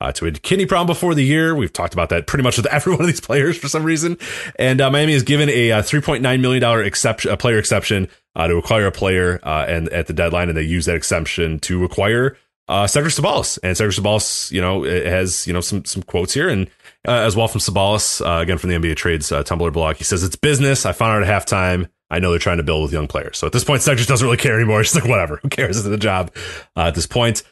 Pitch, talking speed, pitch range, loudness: 100 Hz, 265 wpm, 85-130 Hz, -17 LUFS